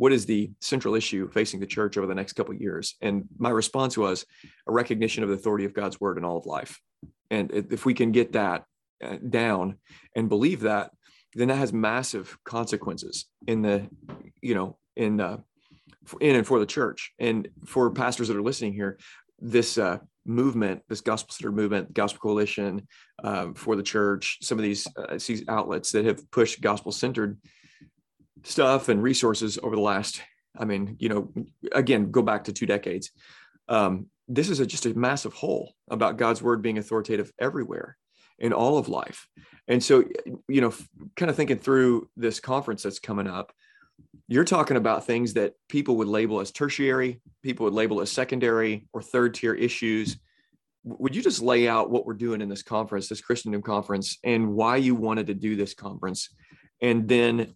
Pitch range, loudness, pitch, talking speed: 105-120 Hz, -26 LUFS, 110 Hz, 185 wpm